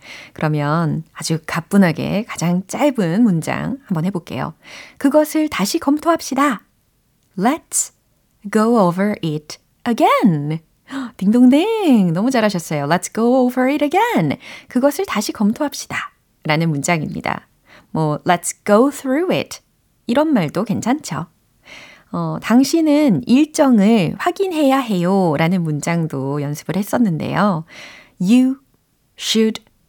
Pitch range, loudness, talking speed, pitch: 170-275 Hz, -17 LUFS, 300 characters per minute, 210 Hz